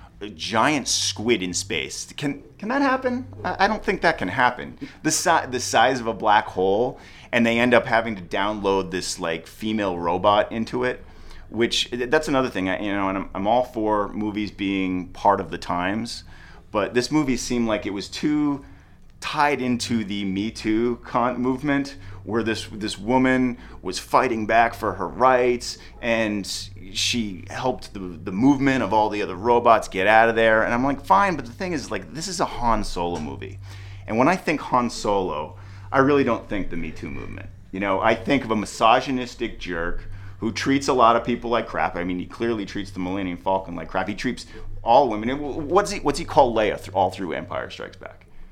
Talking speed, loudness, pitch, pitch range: 205 wpm, -22 LUFS, 110 Hz, 95-125 Hz